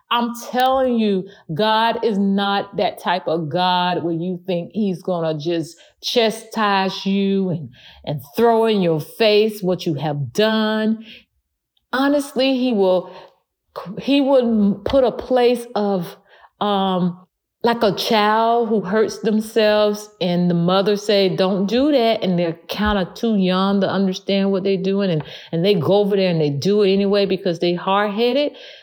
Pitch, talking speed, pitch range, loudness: 200 Hz, 160 wpm, 180-220 Hz, -19 LUFS